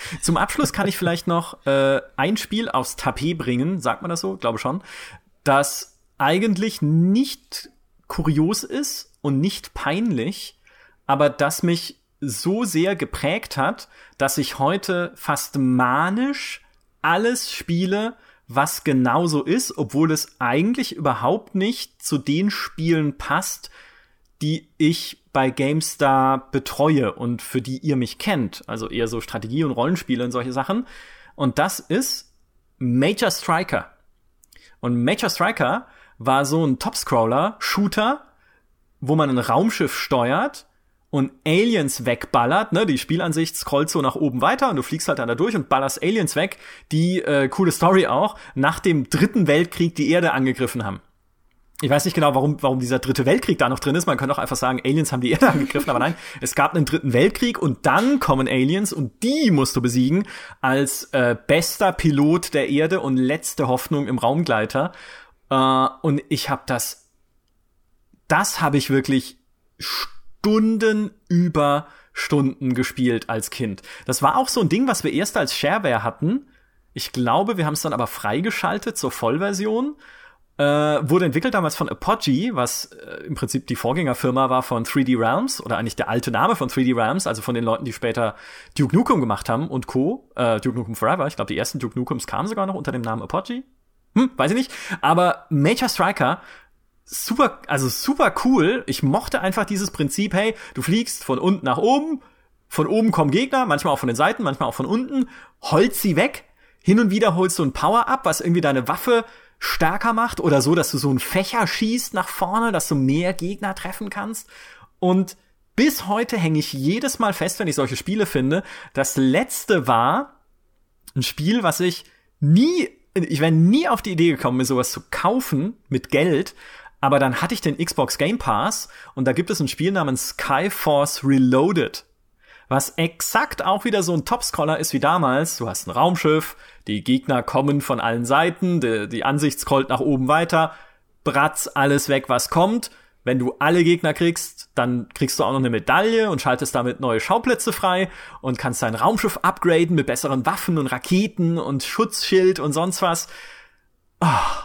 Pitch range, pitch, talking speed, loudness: 130-190 Hz, 150 Hz, 175 wpm, -21 LUFS